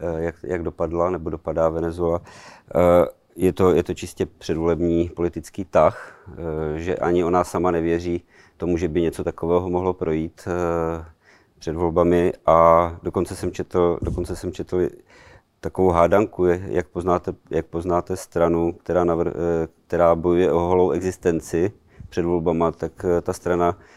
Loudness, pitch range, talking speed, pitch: -22 LUFS, 85-90 Hz, 135 wpm, 85 Hz